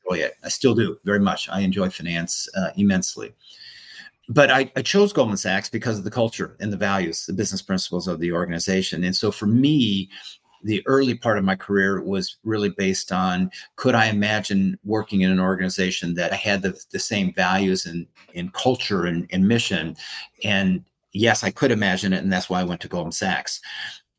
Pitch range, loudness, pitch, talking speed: 95-110 Hz, -22 LUFS, 95 Hz, 195 wpm